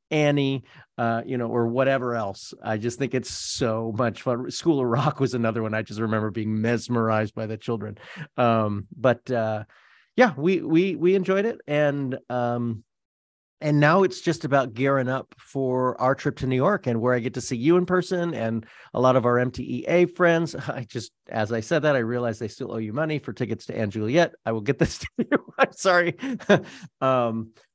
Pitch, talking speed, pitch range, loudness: 125 Hz, 205 wpm, 115-150 Hz, -24 LUFS